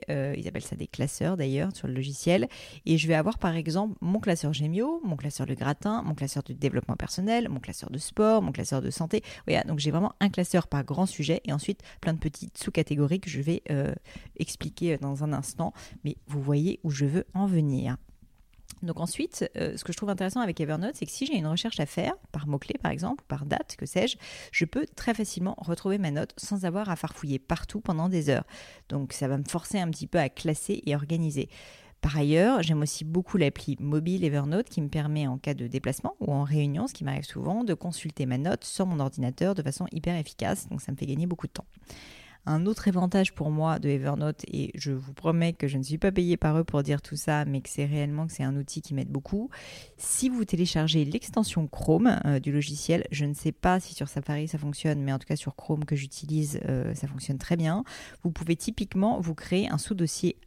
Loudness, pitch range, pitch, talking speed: -29 LUFS, 145-180 Hz, 155 Hz, 230 wpm